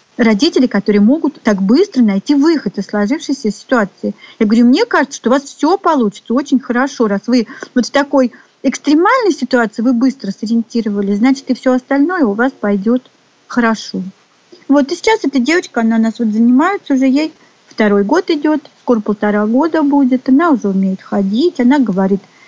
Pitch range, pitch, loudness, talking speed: 220-285 Hz, 255 Hz, -13 LUFS, 170 wpm